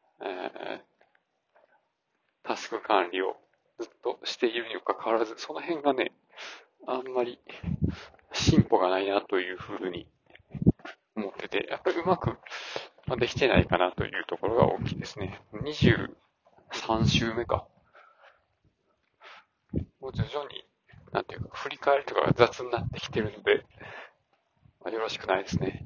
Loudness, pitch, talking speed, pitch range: -29 LUFS, 130 Hz, 260 characters per minute, 105-155 Hz